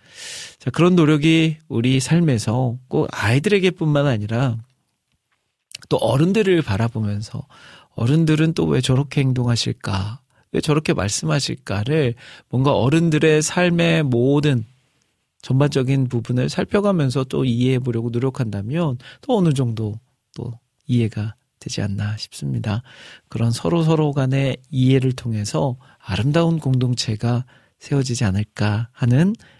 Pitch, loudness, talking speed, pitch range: 130 Hz, -20 LUFS, 280 characters per minute, 120-155 Hz